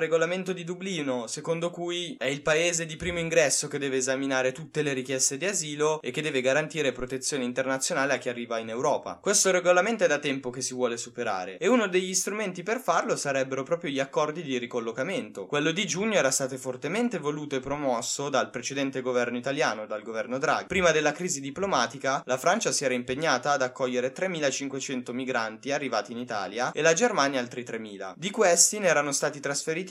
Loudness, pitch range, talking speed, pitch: -27 LUFS, 130-170 Hz, 190 wpm, 140 Hz